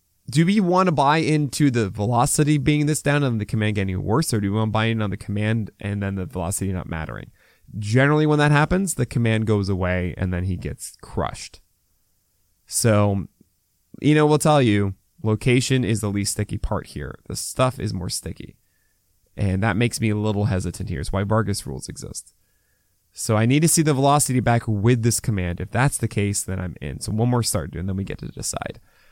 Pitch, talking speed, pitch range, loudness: 105 Hz, 215 wpm, 95-130 Hz, -21 LUFS